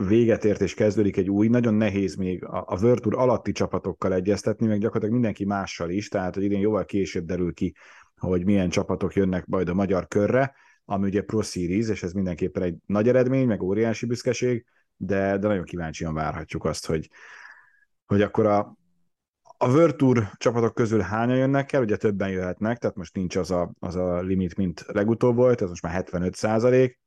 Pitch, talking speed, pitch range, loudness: 100 Hz, 190 wpm, 95-115 Hz, -24 LUFS